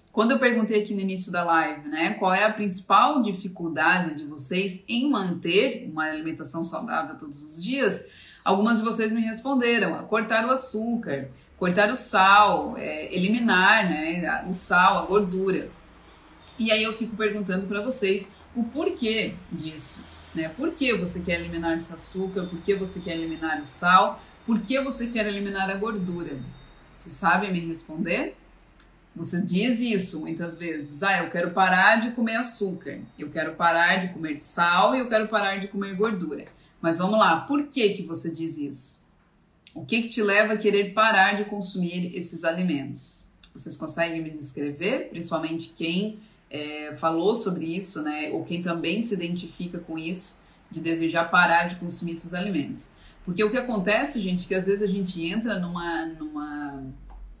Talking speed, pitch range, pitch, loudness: 170 wpm, 165-210 Hz, 185 Hz, -25 LUFS